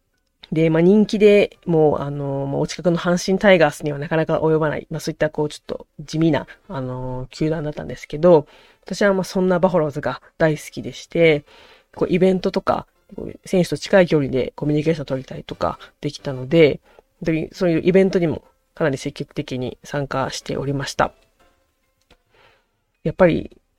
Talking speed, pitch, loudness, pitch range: 375 characters per minute, 155 Hz, -20 LUFS, 145-180 Hz